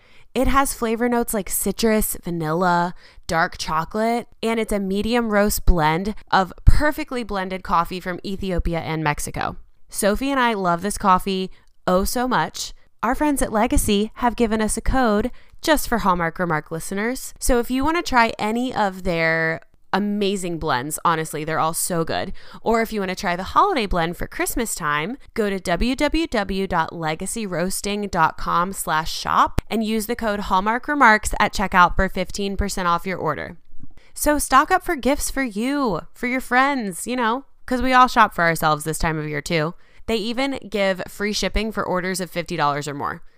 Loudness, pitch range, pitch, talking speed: -21 LUFS, 175-235 Hz, 200 Hz, 175 wpm